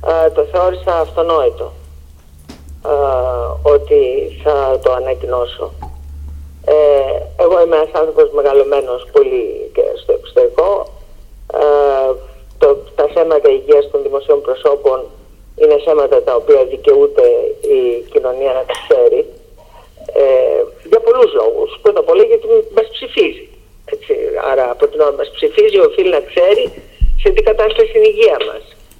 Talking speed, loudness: 130 wpm, -13 LUFS